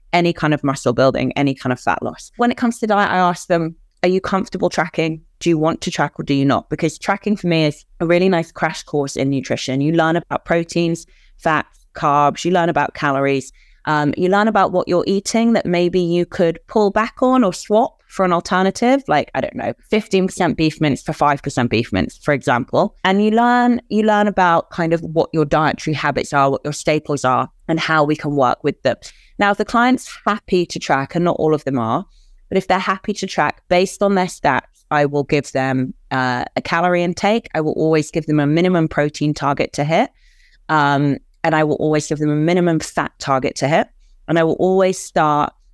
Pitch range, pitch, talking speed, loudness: 145-185 Hz, 165 Hz, 225 wpm, -18 LUFS